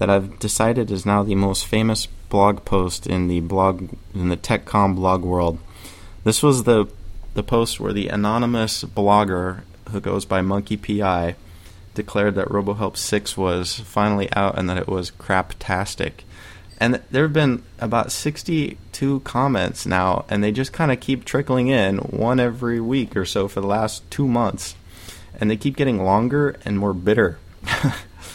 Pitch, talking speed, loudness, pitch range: 100 Hz, 165 wpm, -21 LUFS, 95-115 Hz